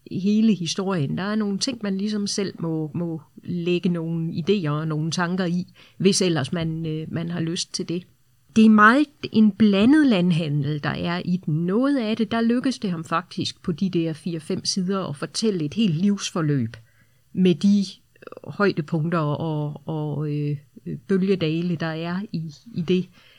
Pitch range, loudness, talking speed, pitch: 160-200 Hz, -23 LUFS, 170 wpm, 175 Hz